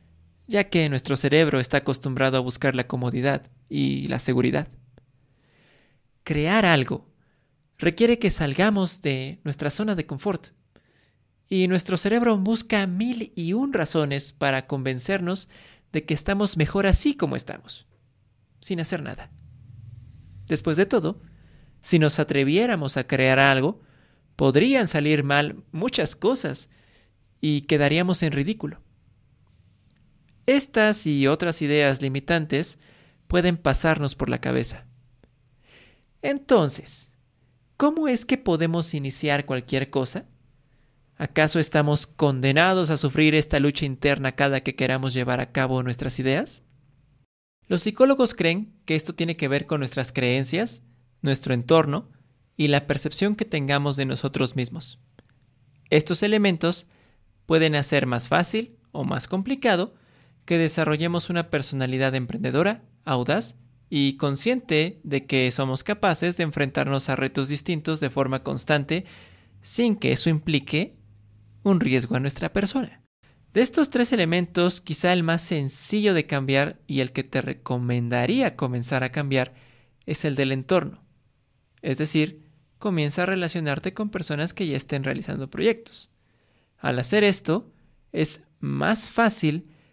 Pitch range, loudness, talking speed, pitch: 130-170 Hz, -24 LUFS, 130 wpm, 145 Hz